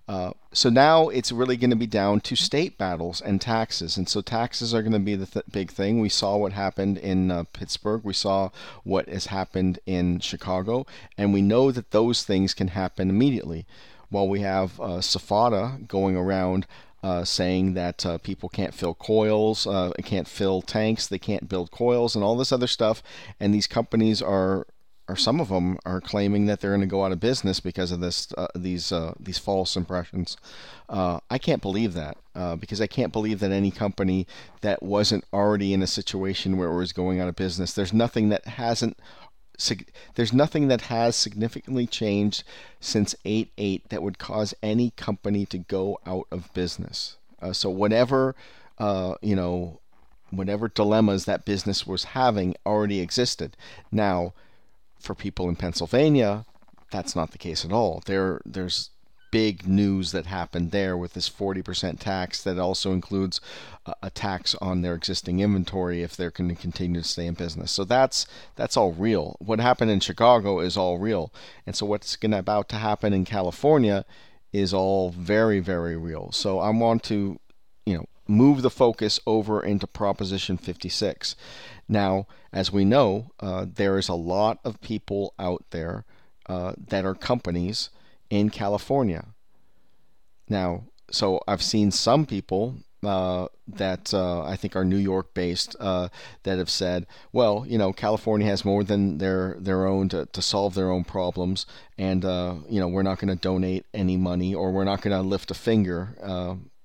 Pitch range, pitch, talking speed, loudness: 90-105 Hz, 95 Hz, 180 wpm, -25 LUFS